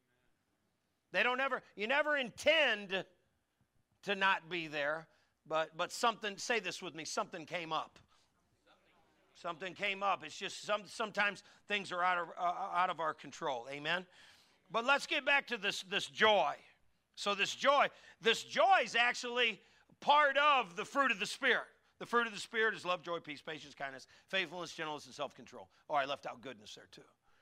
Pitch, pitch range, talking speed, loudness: 195 Hz, 160-235 Hz, 175 wpm, -34 LUFS